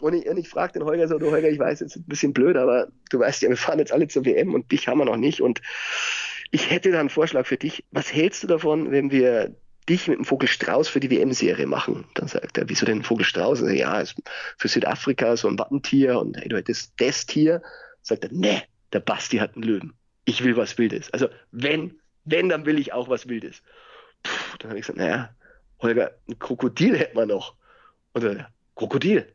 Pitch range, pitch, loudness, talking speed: 130-165 Hz, 155 Hz, -23 LUFS, 230 wpm